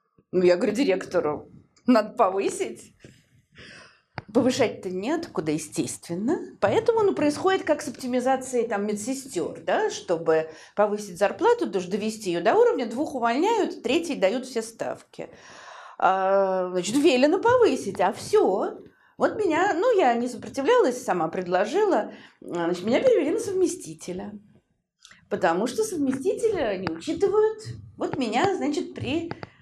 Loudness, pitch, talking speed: -24 LUFS, 265 Hz, 120 wpm